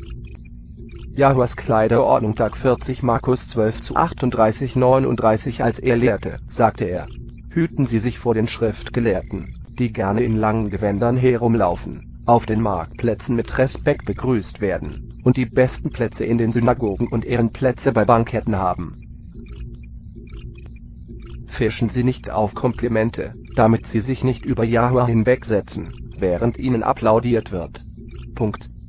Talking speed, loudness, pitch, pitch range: 130 wpm, -20 LUFS, 115 Hz, 105-125 Hz